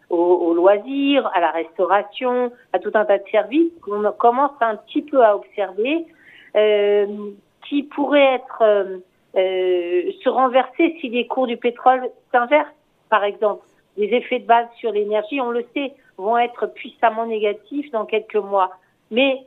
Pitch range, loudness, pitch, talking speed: 205-260 Hz, -19 LUFS, 230 Hz, 155 wpm